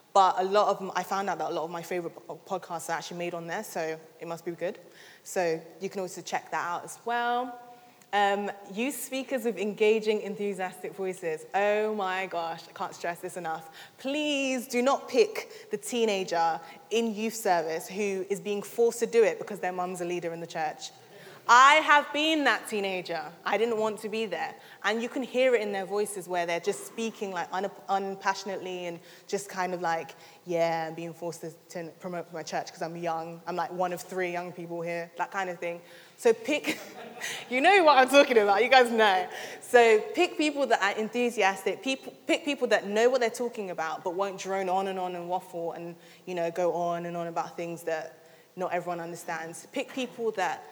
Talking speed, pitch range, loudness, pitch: 205 wpm, 170-225 Hz, -28 LUFS, 190 Hz